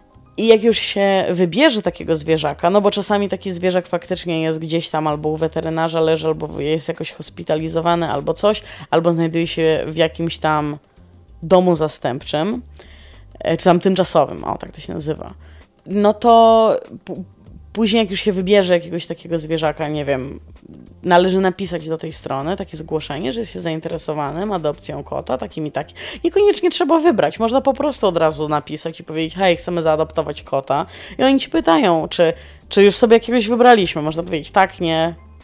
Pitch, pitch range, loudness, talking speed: 165 Hz, 155-200 Hz, -18 LUFS, 170 wpm